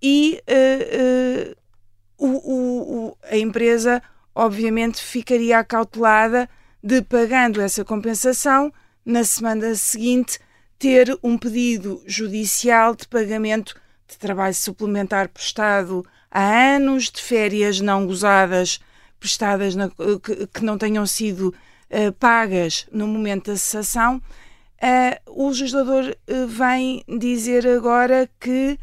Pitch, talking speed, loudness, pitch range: 230 Hz, 95 wpm, -19 LUFS, 205-250 Hz